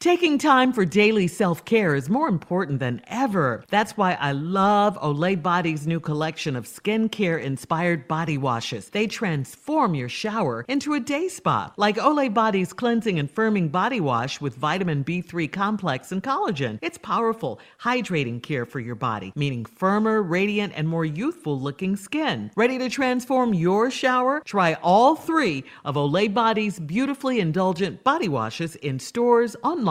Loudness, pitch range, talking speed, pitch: -23 LUFS, 150-230 Hz, 155 wpm, 190 Hz